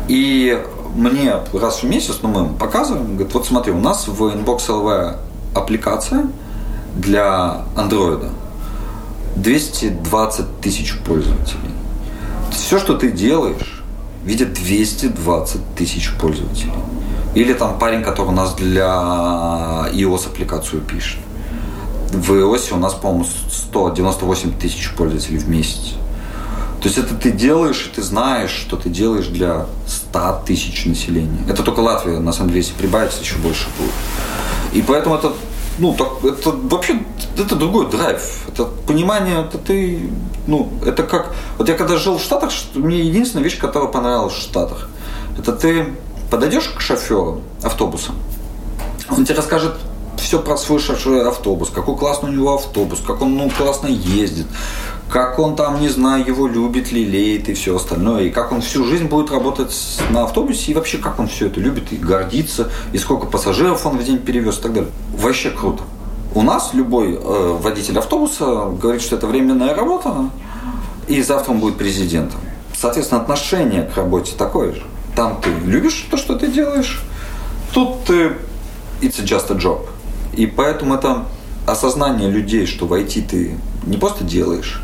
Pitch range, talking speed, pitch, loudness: 90-140 Hz, 155 wpm, 110 Hz, -17 LUFS